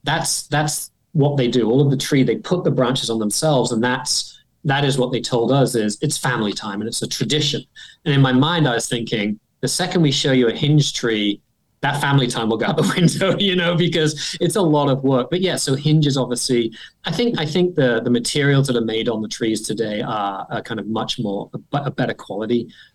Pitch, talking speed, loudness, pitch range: 135 Hz, 240 wpm, -19 LUFS, 120-150 Hz